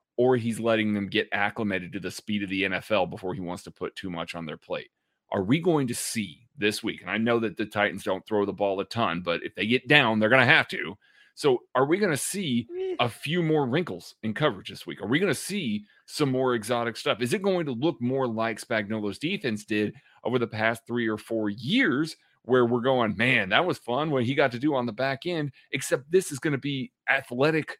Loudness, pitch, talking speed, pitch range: -26 LUFS, 120 Hz, 245 wpm, 105-145 Hz